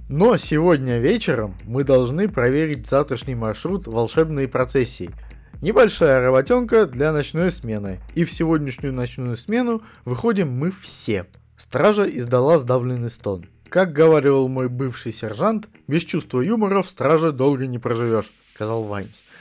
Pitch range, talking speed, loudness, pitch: 120-170 Hz, 130 wpm, -20 LUFS, 135 Hz